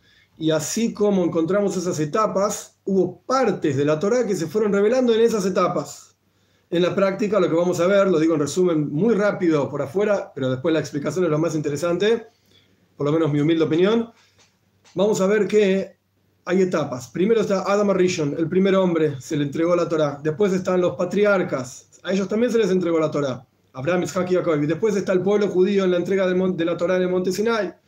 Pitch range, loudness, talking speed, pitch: 150-200 Hz, -21 LUFS, 210 wpm, 180 Hz